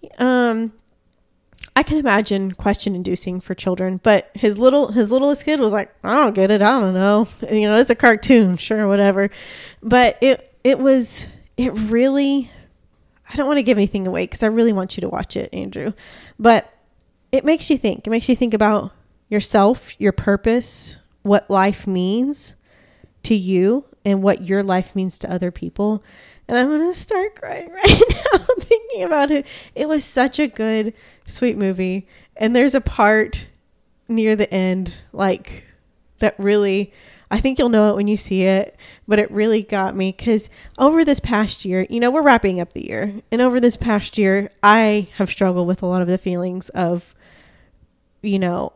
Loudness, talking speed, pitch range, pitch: -18 LUFS, 185 wpm, 195-250 Hz, 215 Hz